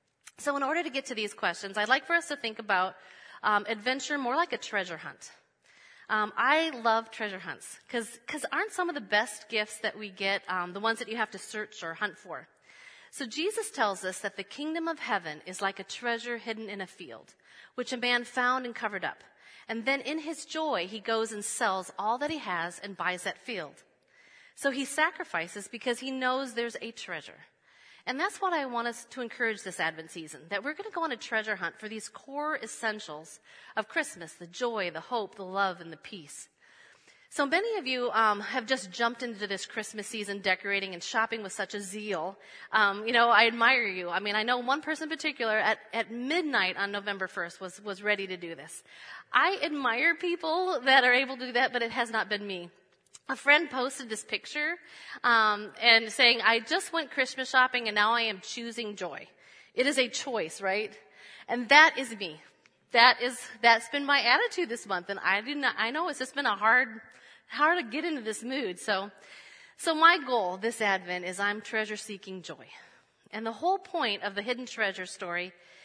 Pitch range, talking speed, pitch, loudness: 200-265 Hz, 210 wpm, 225 Hz, -29 LUFS